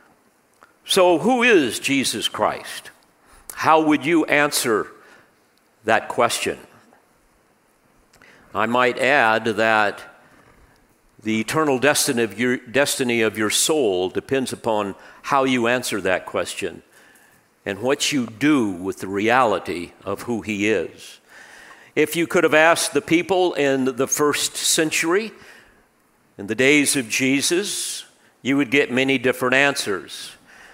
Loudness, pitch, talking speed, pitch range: -19 LUFS, 135 Hz, 125 wpm, 115-150 Hz